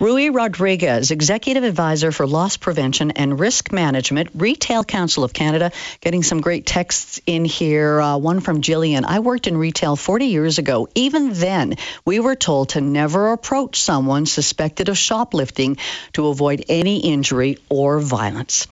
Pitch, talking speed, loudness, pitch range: 165 Hz, 155 wpm, -18 LUFS, 145-195 Hz